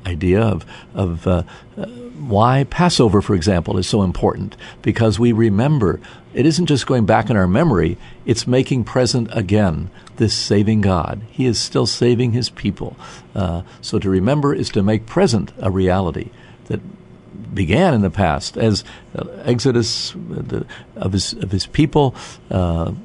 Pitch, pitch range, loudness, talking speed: 110 Hz, 95-125 Hz, -18 LUFS, 165 wpm